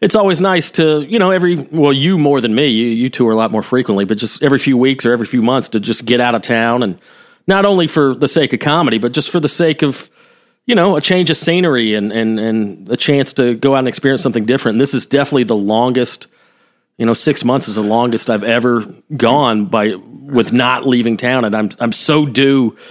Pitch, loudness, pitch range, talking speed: 130 Hz, -13 LUFS, 115-150 Hz, 245 wpm